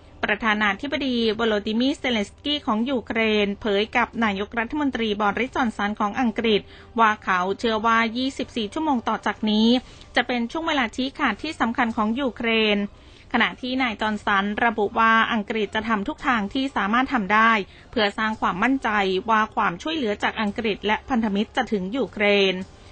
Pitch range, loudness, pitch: 210-250 Hz, -22 LUFS, 225 Hz